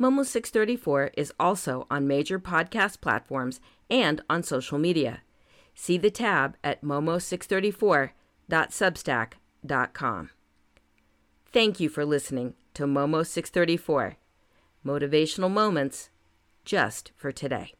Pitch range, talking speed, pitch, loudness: 140-190 Hz, 100 wpm, 155 Hz, -27 LUFS